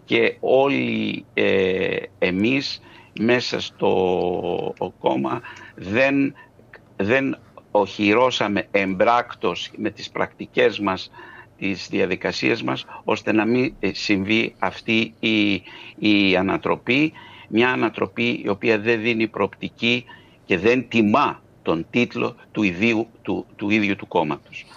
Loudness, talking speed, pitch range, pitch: -21 LUFS, 110 wpm, 105-120 Hz, 115 Hz